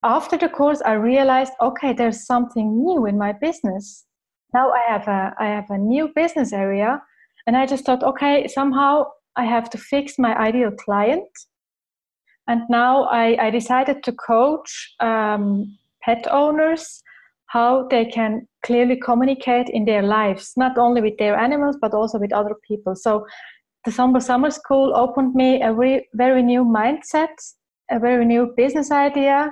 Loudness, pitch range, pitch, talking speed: -19 LUFS, 220-275 Hz, 245 Hz, 165 wpm